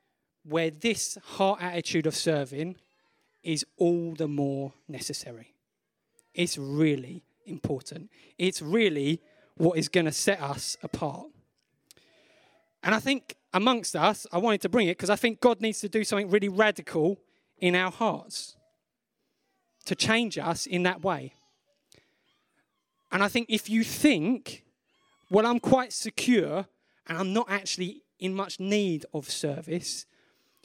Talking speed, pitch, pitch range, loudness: 140 wpm, 185 Hz, 160-215 Hz, -28 LUFS